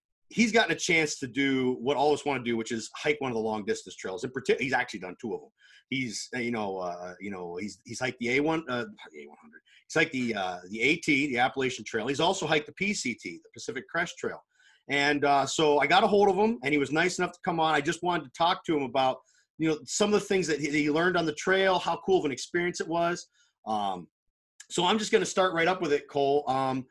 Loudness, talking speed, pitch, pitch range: -28 LUFS, 275 wpm, 150 Hz, 130-180 Hz